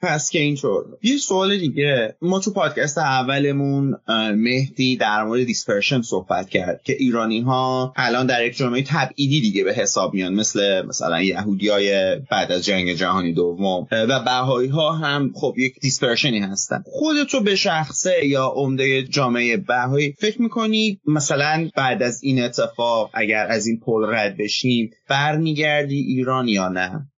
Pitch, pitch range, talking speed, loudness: 130 Hz, 110-150 Hz, 150 wpm, -20 LUFS